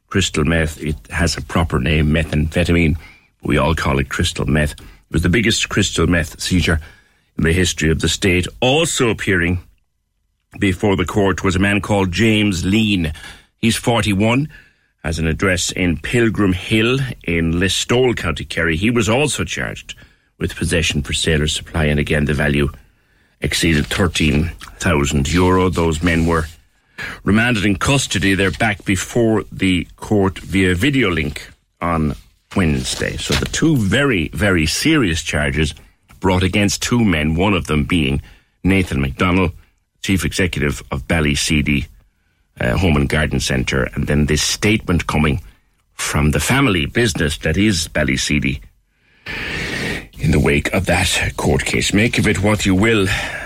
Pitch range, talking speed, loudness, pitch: 75-100 Hz, 150 wpm, -17 LUFS, 85 Hz